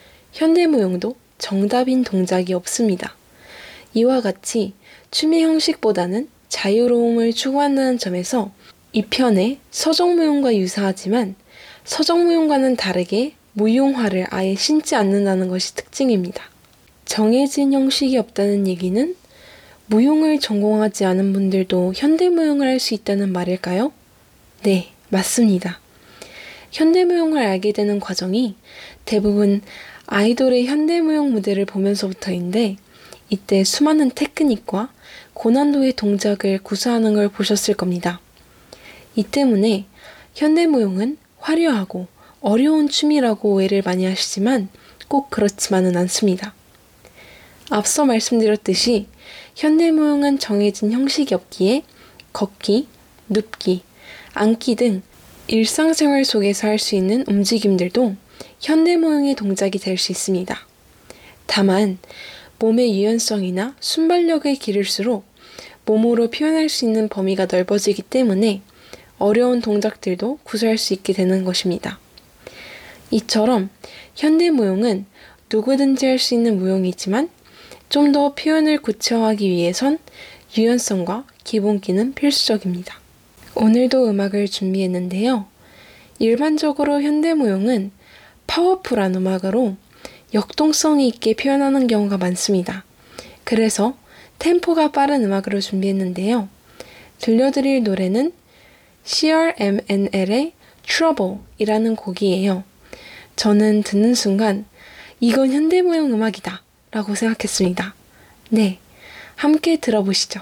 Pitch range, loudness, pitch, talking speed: 195-270 Hz, -18 LUFS, 220 Hz, 275 characters per minute